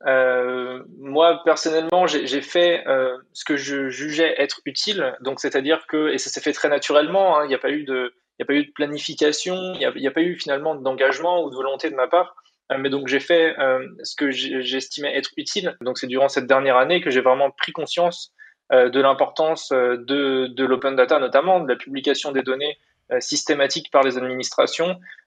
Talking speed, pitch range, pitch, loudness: 215 wpm, 130-165 Hz, 140 Hz, -21 LUFS